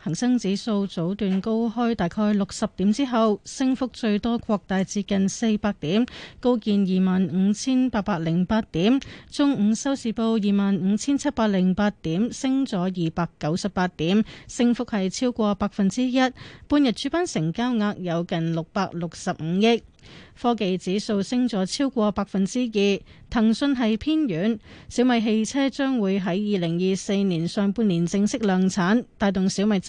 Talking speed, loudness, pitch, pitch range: 245 characters per minute, -23 LUFS, 210 Hz, 190-235 Hz